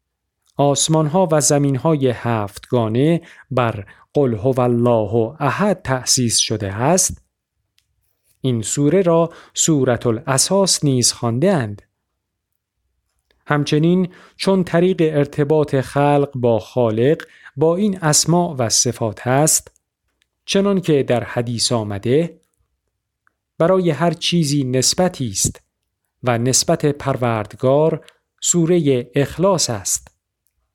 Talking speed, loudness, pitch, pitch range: 95 wpm, -17 LUFS, 130 Hz, 115-160 Hz